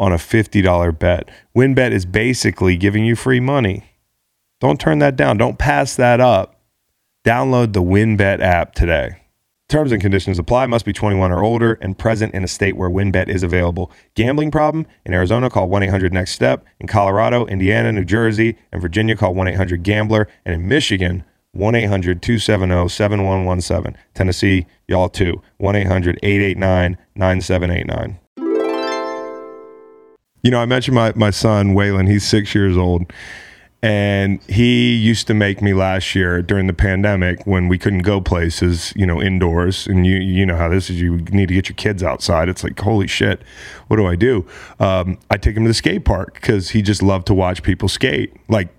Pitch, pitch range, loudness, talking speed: 100 Hz, 90-110 Hz, -16 LUFS, 180 wpm